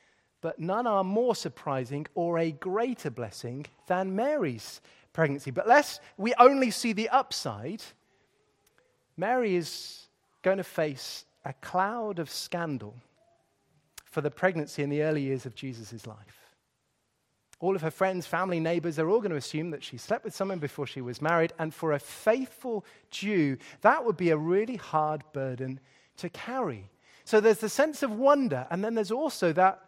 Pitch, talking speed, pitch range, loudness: 170 Hz, 165 wpm, 145-215 Hz, -29 LUFS